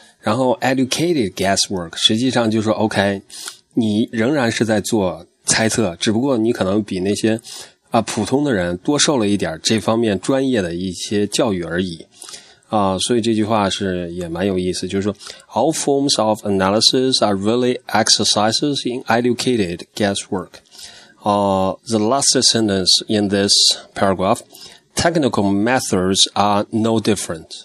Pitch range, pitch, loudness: 100-115 Hz, 110 Hz, -17 LUFS